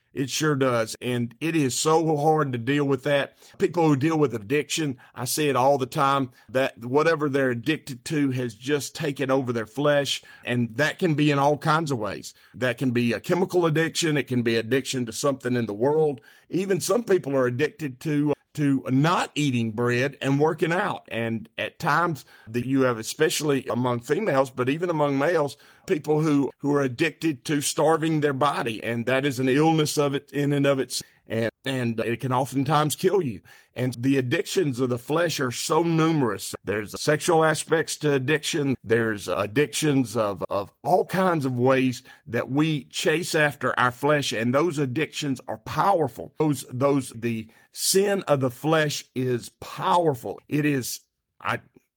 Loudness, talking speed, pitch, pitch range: -24 LUFS, 180 wpm, 140 Hz, 125-155 Hz